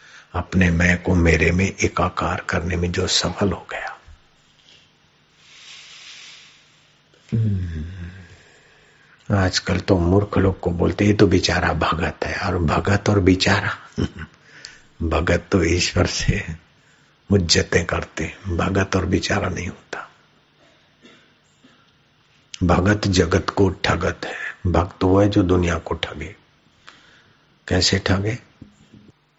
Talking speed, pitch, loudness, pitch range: 110 wpm, 90 Hz, -20 LUFS, 85-100 Hz